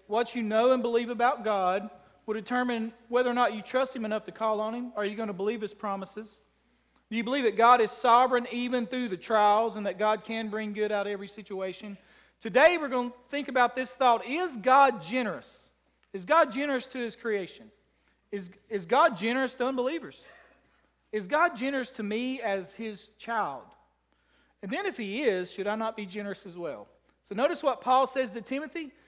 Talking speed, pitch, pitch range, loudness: 205 wpm, 230 Hz, 210-255 Hz, -28 LUFS